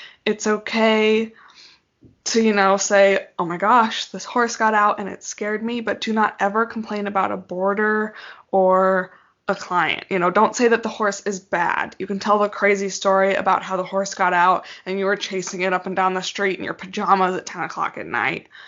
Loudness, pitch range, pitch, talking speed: -20 LUFS, 190-215 Hz, 200 Hz, 215 wpm